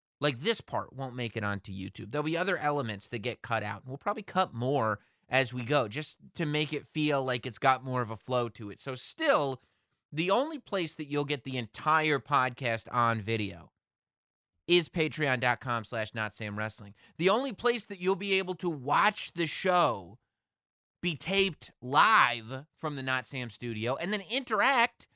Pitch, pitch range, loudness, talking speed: 135 Hz, 120-175 Hz, -30 LUFS, 185 wpm